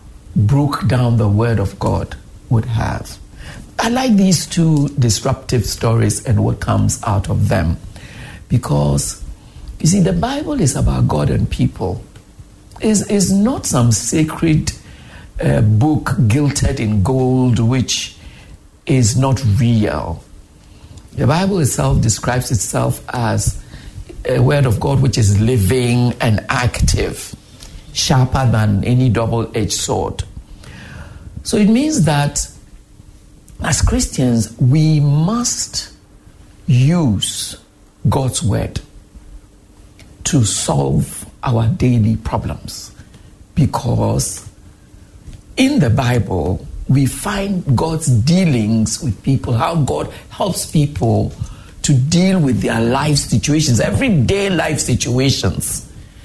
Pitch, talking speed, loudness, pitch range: 120 Hz, 110 wpm, -16 LUFS, 105-145 Hz